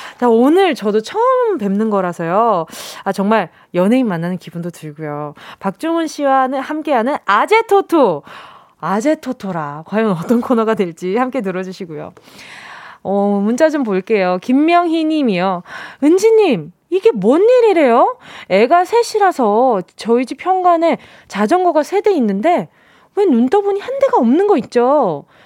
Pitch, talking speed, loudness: 255 Hz, 285 characters per minute, -15 LUFS